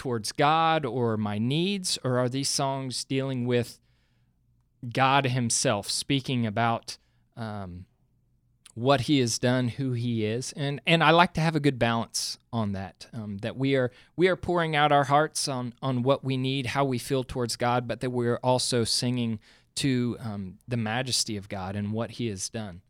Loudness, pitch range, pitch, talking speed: -26 LUFS, 115-135 Hz, 125 Hz, 185 wpm